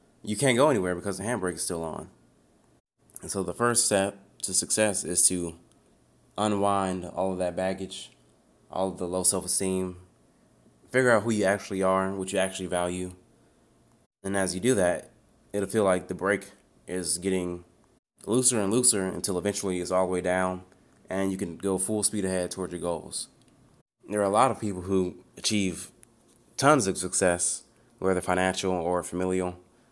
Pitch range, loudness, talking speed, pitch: 90-100 Hz, -27 LUFS, 175 wpm, 95 Hz